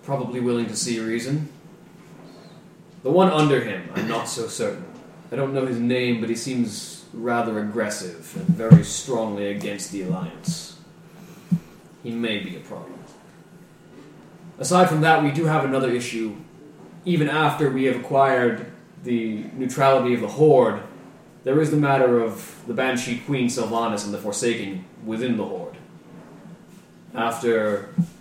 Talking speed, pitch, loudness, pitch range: 145 wpm, 130 Hz, -22 LUFS, 115-160 Hz